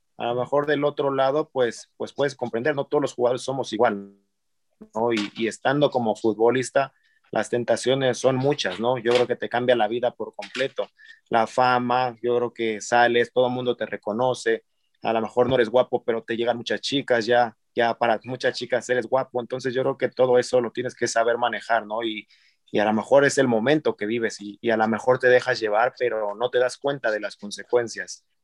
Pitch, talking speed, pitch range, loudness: 120 Hz, 215 wpm, 115-130 Hz, -23 LUFS